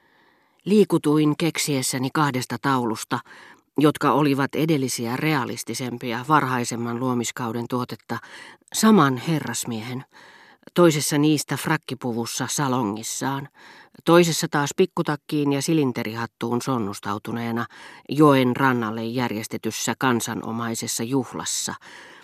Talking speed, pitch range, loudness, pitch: 75 wpm, 120-150 Hz, -23 LUFS, 130 Hz